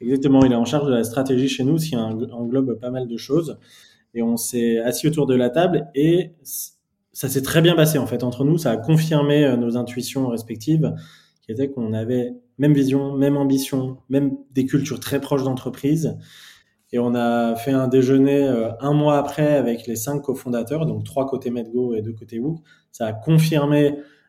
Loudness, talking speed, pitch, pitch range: -20 LUFS, 195 wpm, 135 Hz, 120-145 Hz